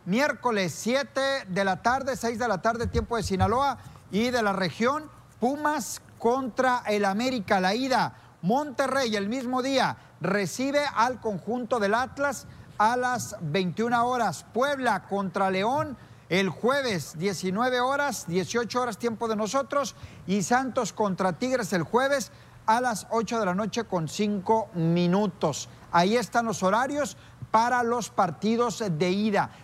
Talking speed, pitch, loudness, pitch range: 145 wpm, 225 Hz, -26 LUFS, 190-250 Hz